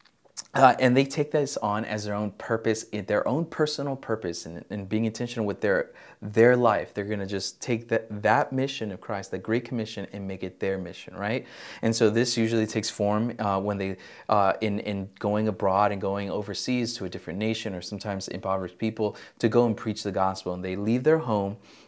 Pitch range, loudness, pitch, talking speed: 100-115 Hz, -27 LUFS, 105 Hz, 215 wpm